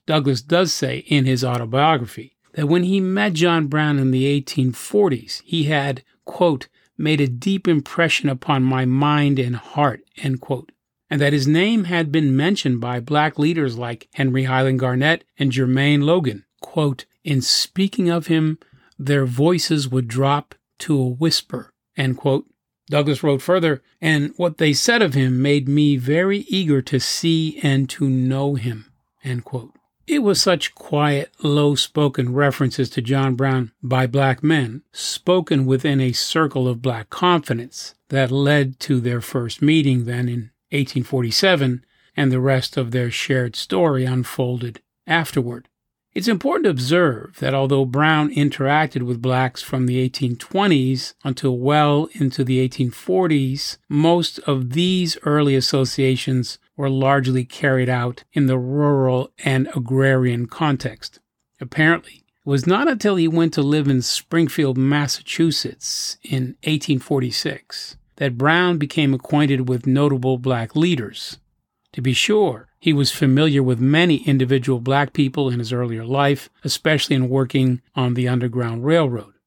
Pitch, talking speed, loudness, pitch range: 140 Hz, 150 wpm, -19 LUFS, 130-155 Hz